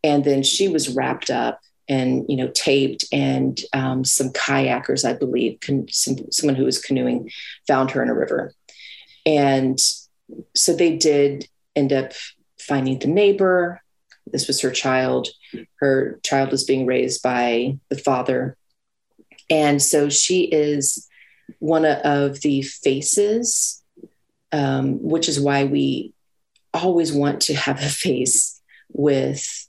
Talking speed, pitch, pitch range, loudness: 135 wpm, 140 Hz, 130-150 Hz, -20 LUFS